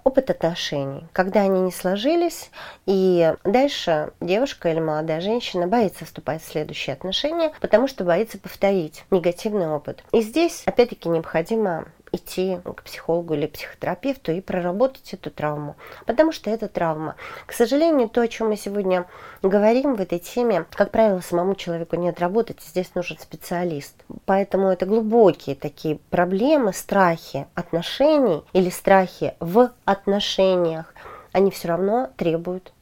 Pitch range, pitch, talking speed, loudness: 165-220 Hz, 185 Hz, 135 wpm, -22 LUFS